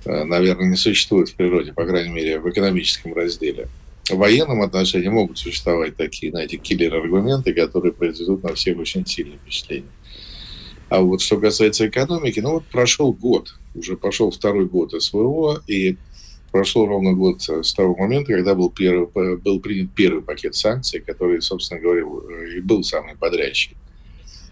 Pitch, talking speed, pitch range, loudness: 100 Hz, 150 wpm, 90-150 Hz, -19 LUFS